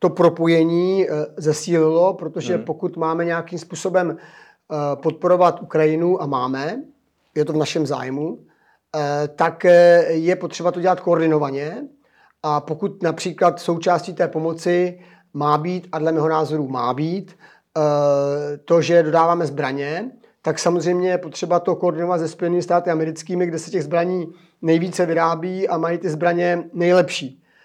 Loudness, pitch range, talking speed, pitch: -20 LUFS, 155-180 Hz, 135 wpm, 170 Hz